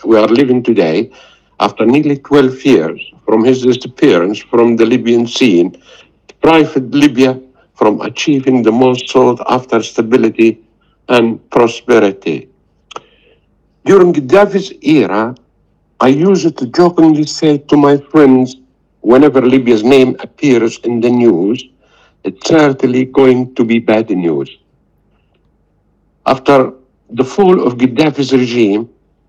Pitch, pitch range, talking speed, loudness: 130 Hz, 115-145 Hz, 115 wpm, -11 LUFS